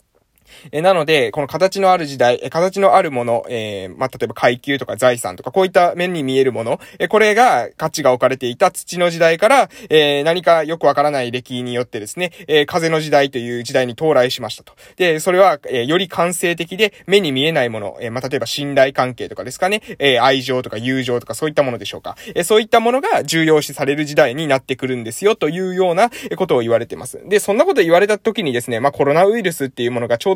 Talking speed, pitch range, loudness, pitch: 475 characters per minute, 130-180 Hz, -16 LUFS, 150 Hz